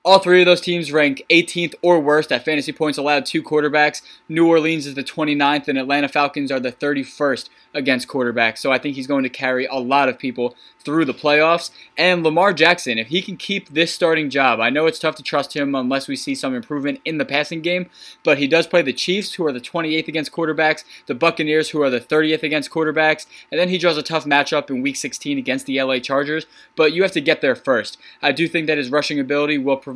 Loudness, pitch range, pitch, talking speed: -18 LUFS, 140-165 Hz, 150 Hz, 235 wpm